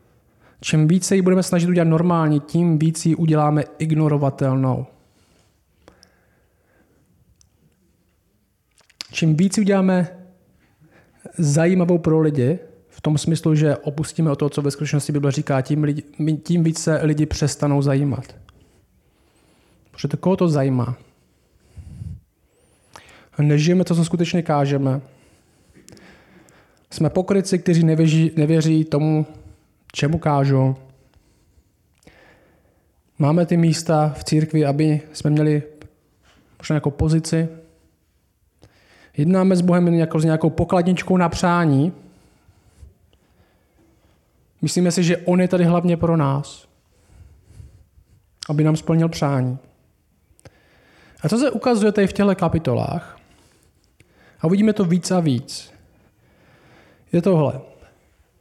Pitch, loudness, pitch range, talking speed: 150 Hz, -19 LUFS, 120-170 Hz, 110 wpm